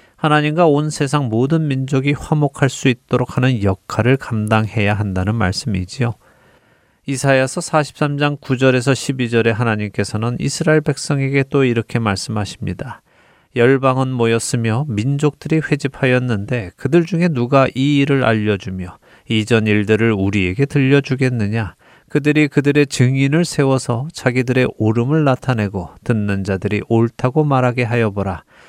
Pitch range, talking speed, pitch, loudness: 110-140 Hz, 320 characters per minute, 125 Hz, -17 LUFS